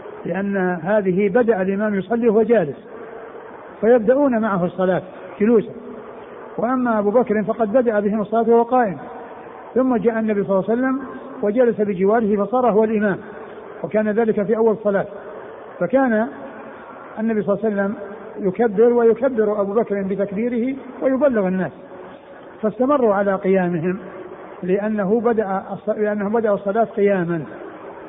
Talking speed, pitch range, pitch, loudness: 120 wpm, 200-230 Hz, 215 Hz, -19 LUFS